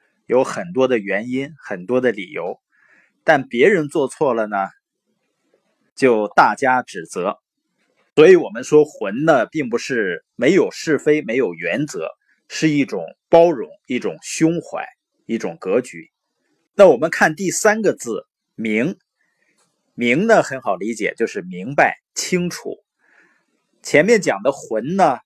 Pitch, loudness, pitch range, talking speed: 150 Hz, -18 LUFS, 130-185 Hz, 195 characters per minute